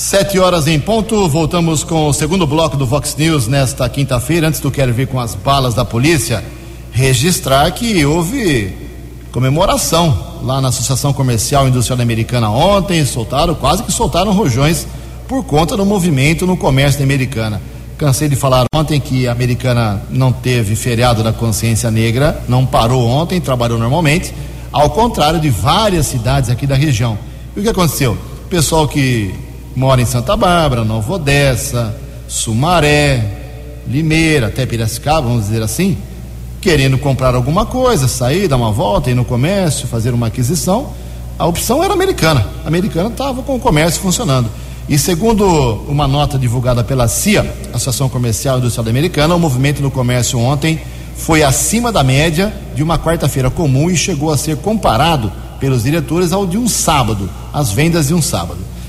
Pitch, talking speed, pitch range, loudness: 135 Hz, 160 wpm, 120-160 Hz, -13 LUFS